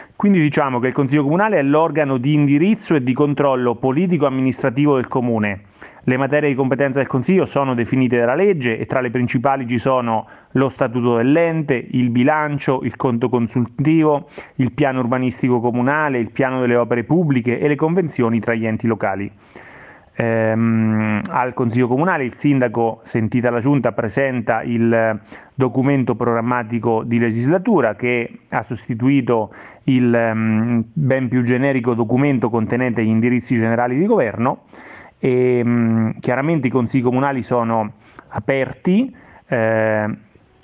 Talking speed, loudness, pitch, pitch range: 135 wpm, -18 LUFS, 125 Hz, 115-140 Hz